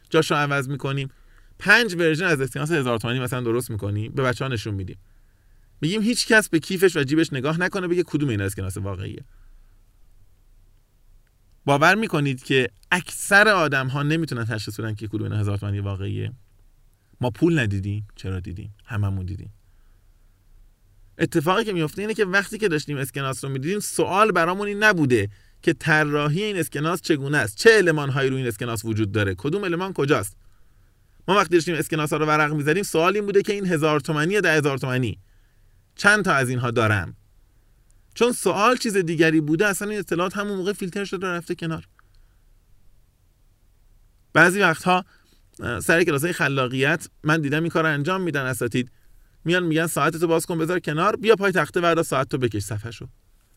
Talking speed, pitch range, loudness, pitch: 165 wpm, 105-170 Hz, -22 LUFS, 135 Hz